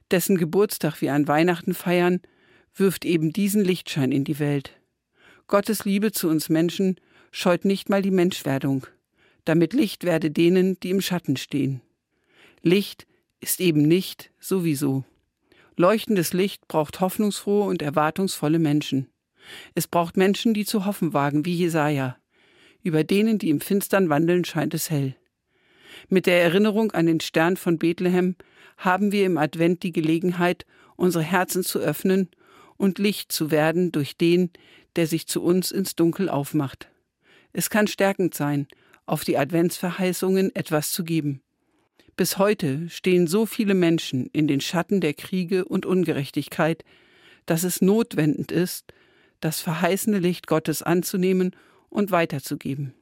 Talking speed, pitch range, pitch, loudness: 145 wpm, 155-190 Hz, 175 Hz, -23 LUFS